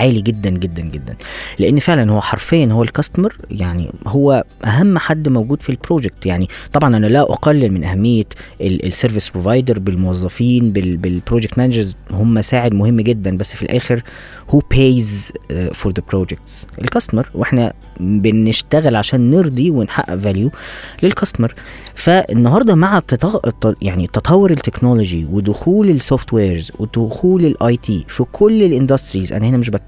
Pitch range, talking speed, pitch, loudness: 95-135 Hz, 135 wpm, 115 Hz, -15 LUFS